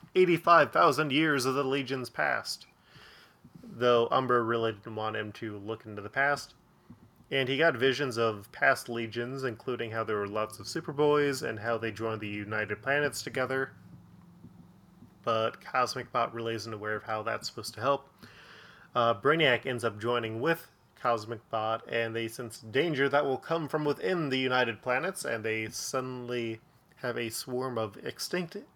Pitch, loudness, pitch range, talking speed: 120 Hz, -30 LUFS, 115-140 Hz, 165 wpm